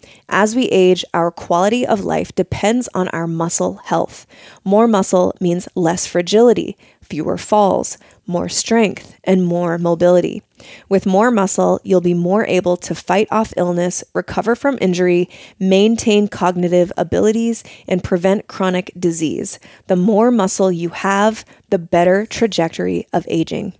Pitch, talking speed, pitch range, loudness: 185 Hz, 140 wpm, 175-210 Hz, -16 LUFS